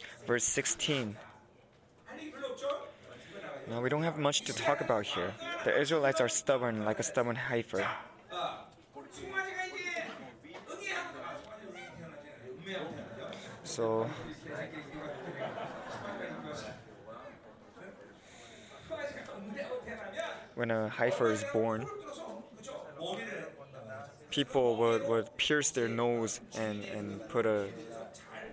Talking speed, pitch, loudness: 75 wpm, 130 Hz, -34 LUFS